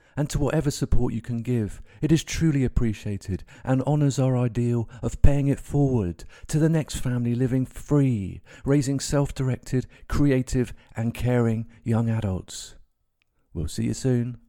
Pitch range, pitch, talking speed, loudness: 115-140 Hz, 125 Hz, 155 wpm, -25 LUFS